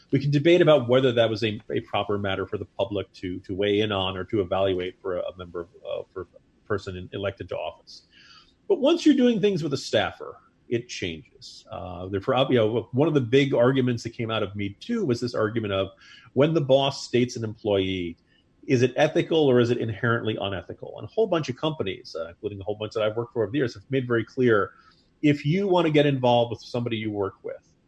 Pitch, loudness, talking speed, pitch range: 115 Hz, -25 LUFS, 235 wpm, 100-140 Hz